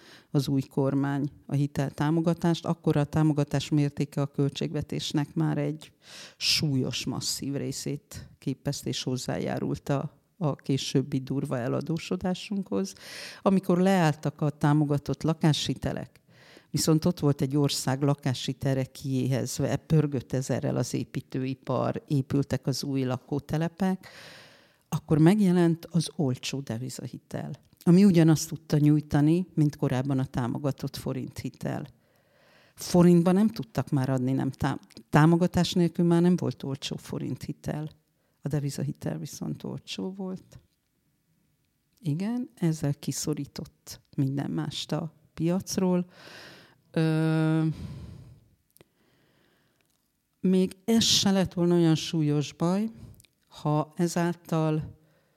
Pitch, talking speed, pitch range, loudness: 150 Hz, 105 wpm, 135-165 Hz, -27 LUFS